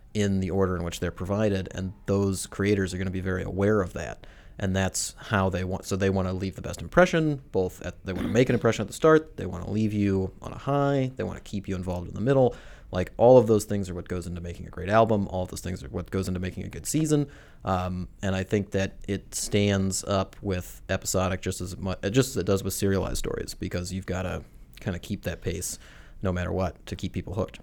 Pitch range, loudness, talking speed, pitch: 90-105 Hz, -27 LUFS, 260 wpm, 95 Hz